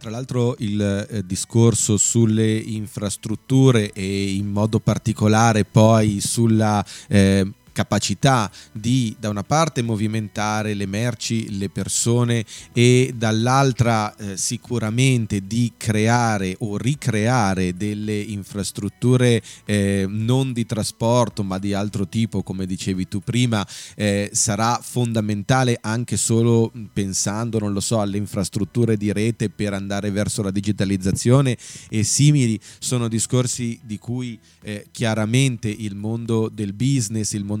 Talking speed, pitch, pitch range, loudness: 125 wpm, 110 Hz, 100-120 Hz, -20 LUFS